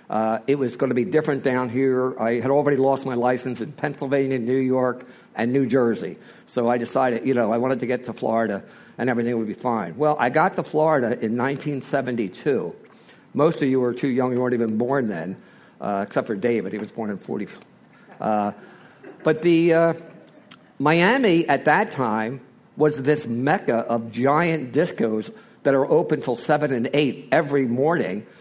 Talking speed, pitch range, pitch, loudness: 190 wpm, 120-145 Hz, 130 Hz, -22 LUFS